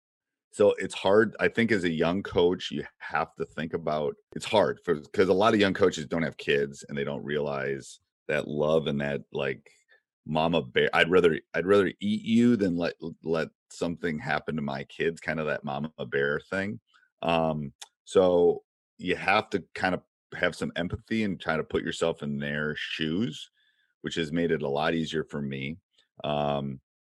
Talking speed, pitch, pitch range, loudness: 185 wpm, 80 Hz, 70-95 Hz, -28 LUFS